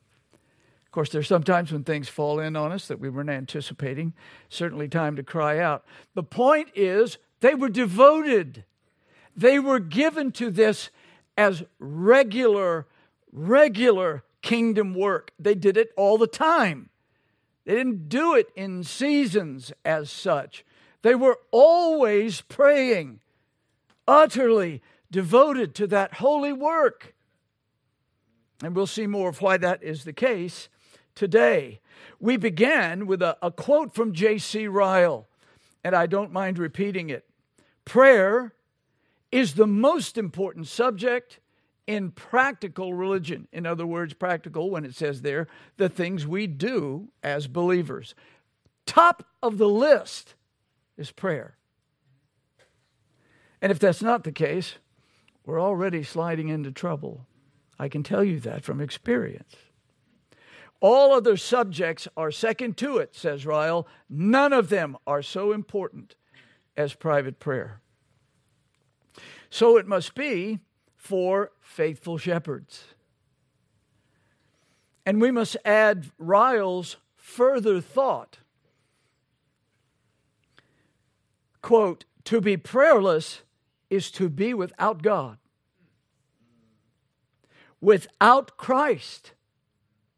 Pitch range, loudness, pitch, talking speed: 150-230 Hz, -23 LUFS, 185 Hz, 115 wpm